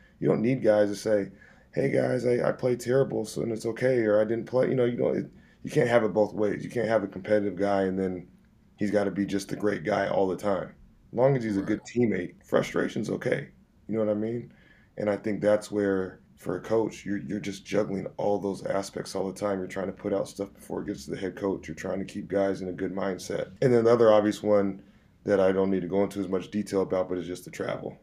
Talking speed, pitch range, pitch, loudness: 270 wpm, 95-110 Hz, 105 Hz, -28 LUFS